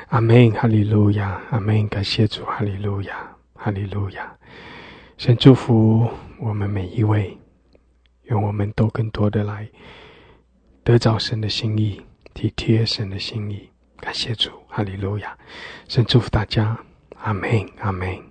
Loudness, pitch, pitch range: -20 LUFS, 105 Hz, 100-115 Hz